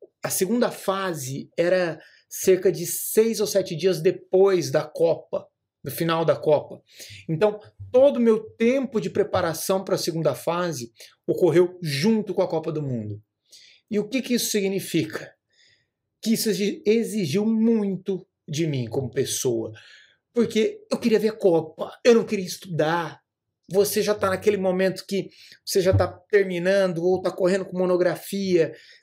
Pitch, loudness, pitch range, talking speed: 190 Hz, -23 LUFS, 165-210 Hz, 155 wpm